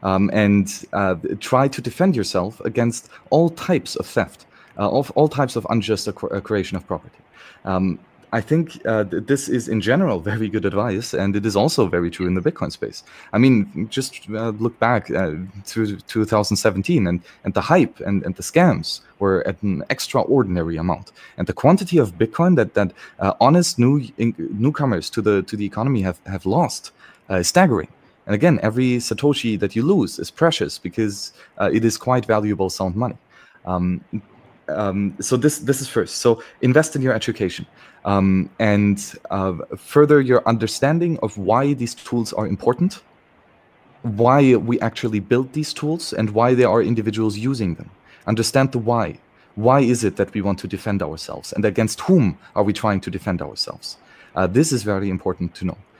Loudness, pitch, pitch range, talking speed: -20 LUFS, 110 Hz, 100-125 Hz, 185 wpm